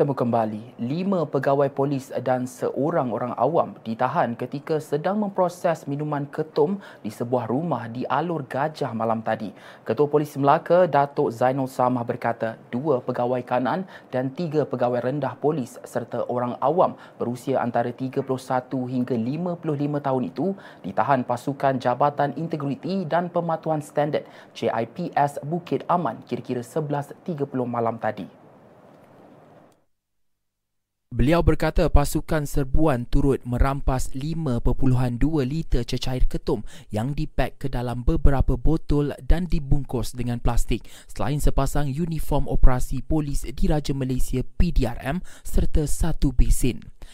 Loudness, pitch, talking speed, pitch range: -25 LUFS, 135 Hz, 115 wpm, 125-150 Hz